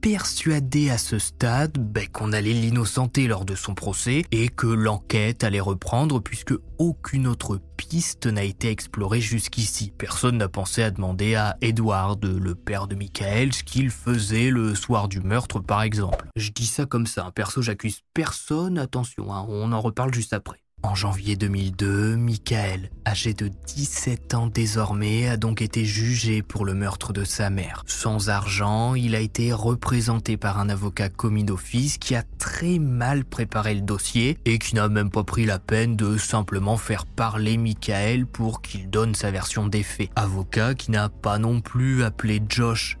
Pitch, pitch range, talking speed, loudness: 110 Hz, 100-120 Hz, 175 wpm, -24 LUFS